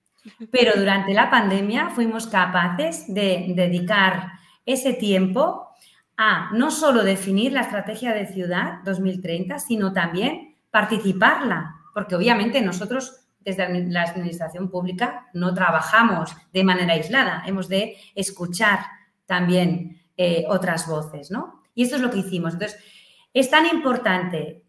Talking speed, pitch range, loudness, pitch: 125 wpm, 180-230 Hz, -21 LUFS, 195 Hz